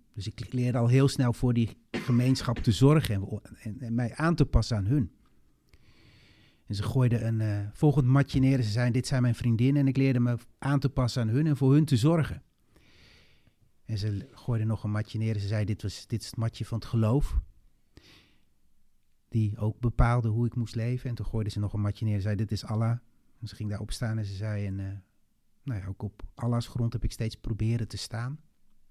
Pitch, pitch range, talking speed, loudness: 115 Hz, 105-125 Hz, 230 wpm, -28 LUFS